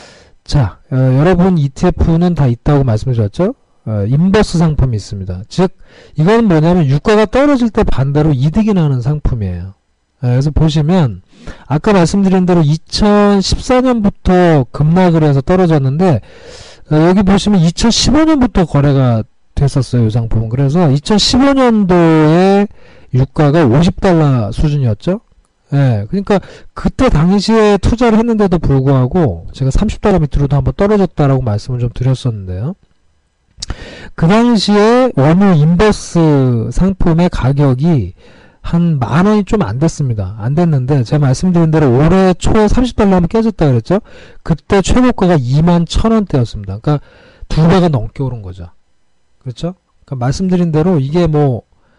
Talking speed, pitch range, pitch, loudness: 300 characters per minute, 130-190 Hz, 160 Hz, -12 LUFS